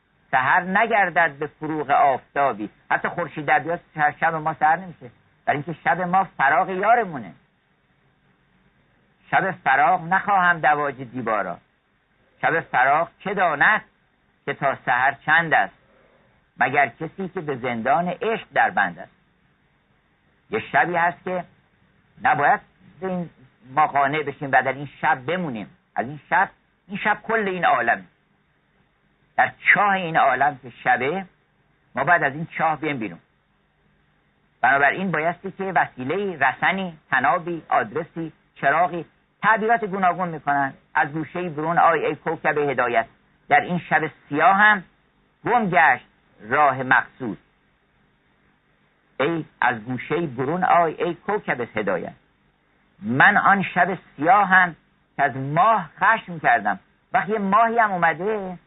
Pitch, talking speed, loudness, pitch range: 165 Hz, 130 wpm, -21 LUFS, 145-185 Hz